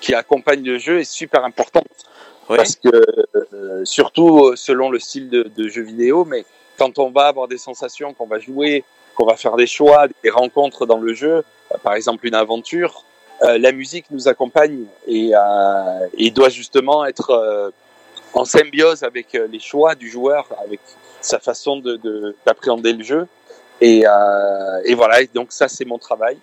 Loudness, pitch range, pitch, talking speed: -15 LUFS, 115-155 Hz, 130 Hz, 180 wpm